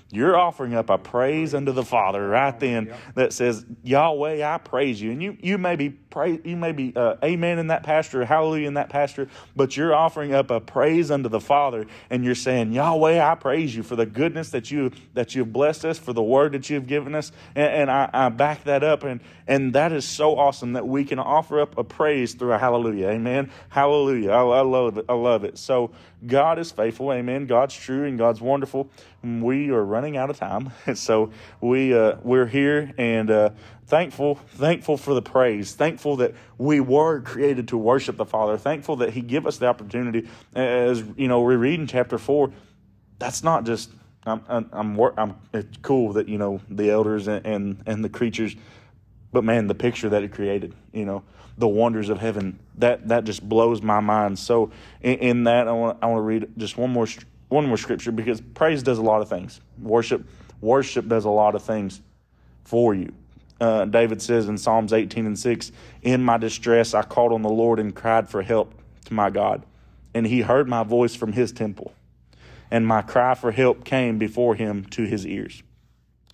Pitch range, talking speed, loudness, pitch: 110-140 Hz, 210 wpm, -22 LUFS, 120 Hz